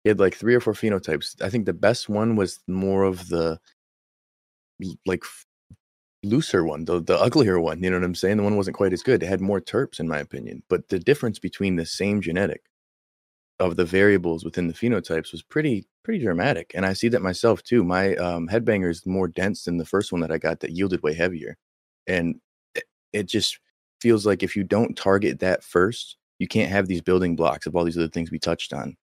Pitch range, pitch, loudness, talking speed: 85-100 Hz, 95 Hz, -23 LUFS, 220 wpm